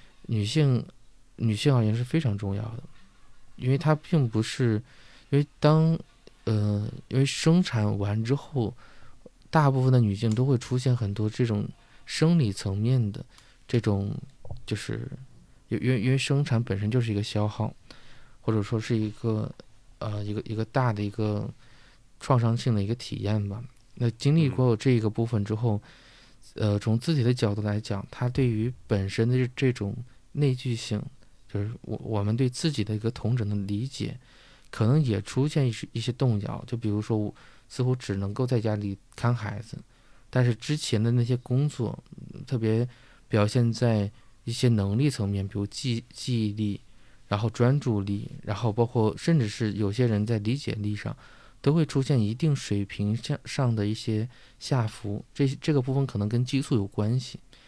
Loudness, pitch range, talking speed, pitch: -27 LUFS, 105-130 Hz, 250 characters per minute, 115 Hz